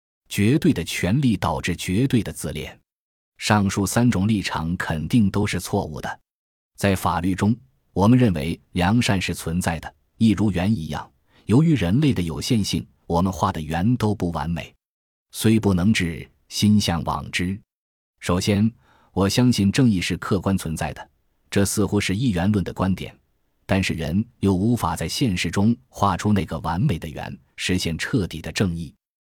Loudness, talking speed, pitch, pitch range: -22 LUFS, 240 characters per minute, 95 Hz, 85-105 Hz